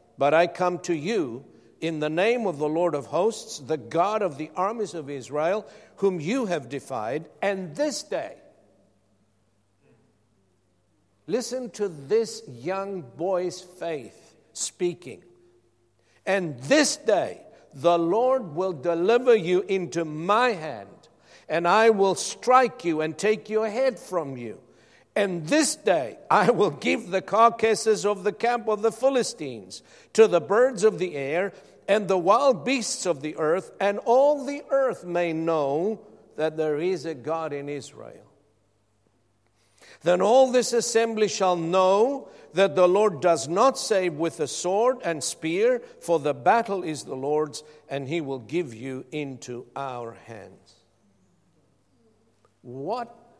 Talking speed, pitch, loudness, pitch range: 145 wpm, 175 Hz, -24 LUFS, 140-215 Hz